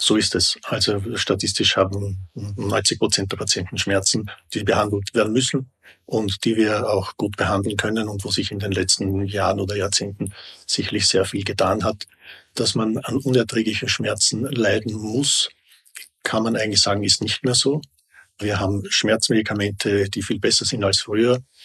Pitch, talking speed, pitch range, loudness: 105 Hz, 165 wpm, 100-115 Hz, -20 LUFS